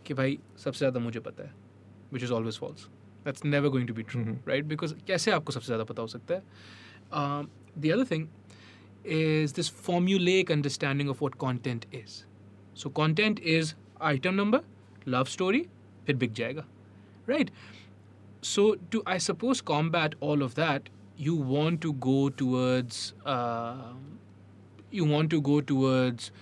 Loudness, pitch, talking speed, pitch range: -29 LUFS, 130 Hz, 130 wpm, 105-155 Hz